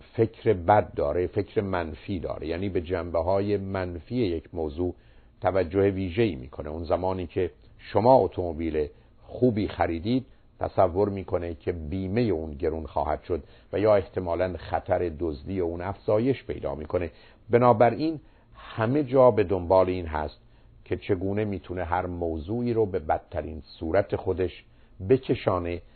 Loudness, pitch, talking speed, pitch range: -27 LUFS, 95 Hz, 135 wpm, 90-110 Hz